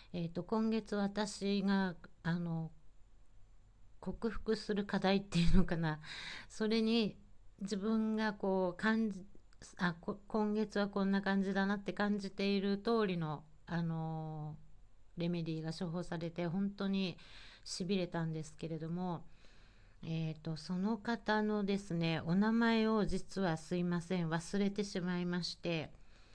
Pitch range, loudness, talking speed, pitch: 165-205 Hz, -37 LUFS, 250 characters per minute, 185 Hz